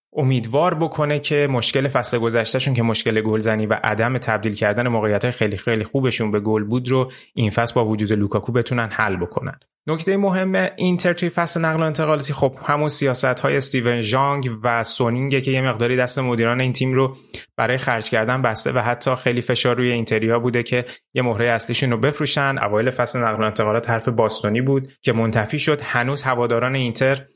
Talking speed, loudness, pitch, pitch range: 185 wpm, -19 LUFS, 125 Hz, 115-135 Hz